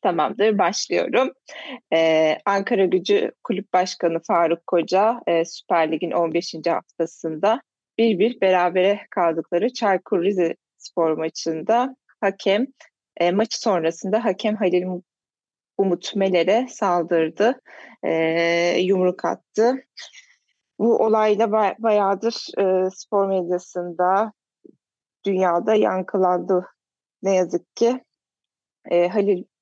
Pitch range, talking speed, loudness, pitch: 175-220 Hz, 90 wpm, -21 LUFS, 190 Hz